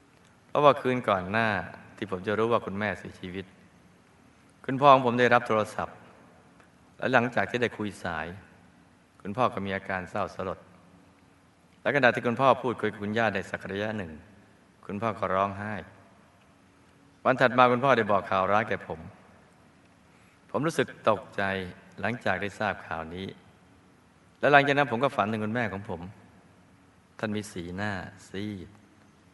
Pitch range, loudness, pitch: 95-110 Hz, -27 LUFS, 100 Hz